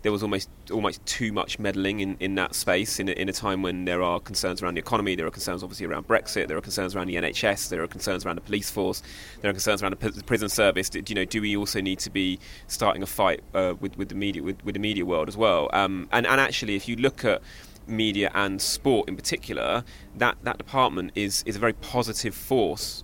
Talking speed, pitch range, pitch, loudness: 245 wpm, 95-105 Hz, 100 Hz, -26 LUFS